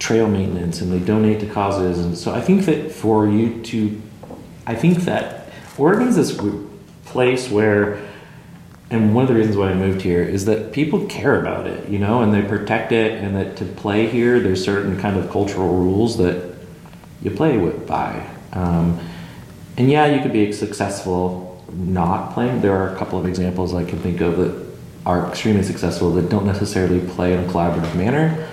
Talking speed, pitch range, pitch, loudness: 190 wpm, 90-110 Hz, 100 Hz, -19 LUFS